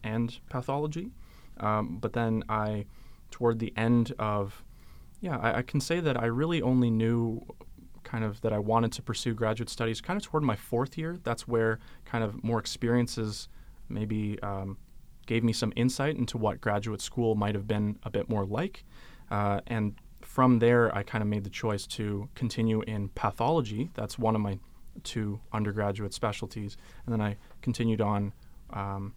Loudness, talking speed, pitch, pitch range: -30 LUFS, 175 wpm, 110 Hz, 105-120 Hz